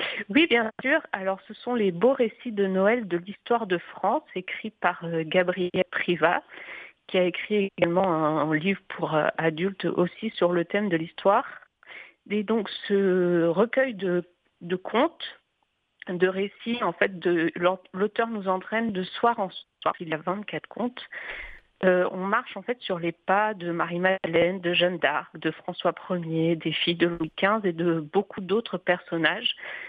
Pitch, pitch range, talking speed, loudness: 185 Hz, 175-210 Hz, 165 wpm, -26 LUFS